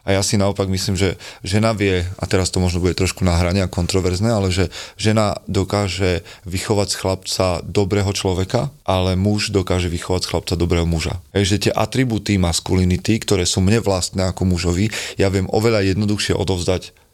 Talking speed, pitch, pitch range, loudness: 170 wpm, 95 Hz, 90-100 Hz, -19 LUFS